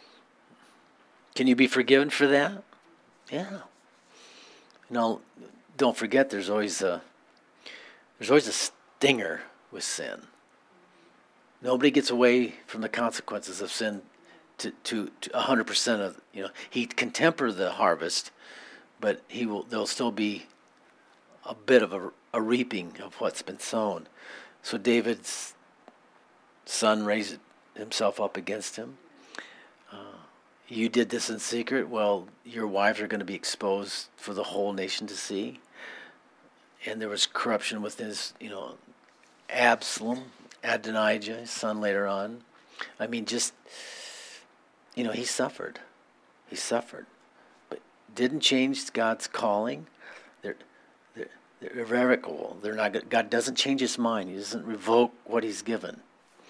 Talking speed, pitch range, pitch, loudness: 135 wpm, 105-125 Hz, 115 Hz, -28 LUFS